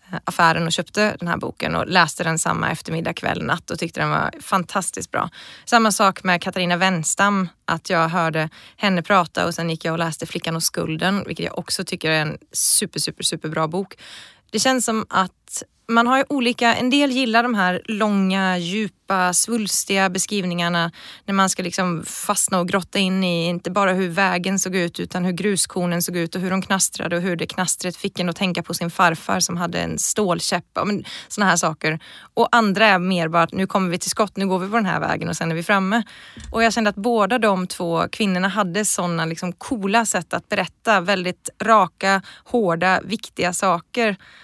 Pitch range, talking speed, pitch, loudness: 175-210 Hz, 205 wpm, 190 Hz, -20 LUFS